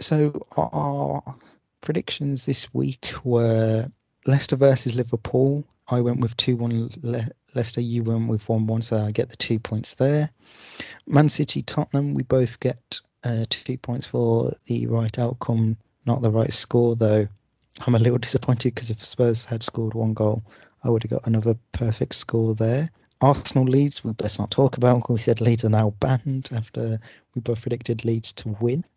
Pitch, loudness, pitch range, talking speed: 120 Hz, -23 LUFS, 115-130 Hz, 180 wpm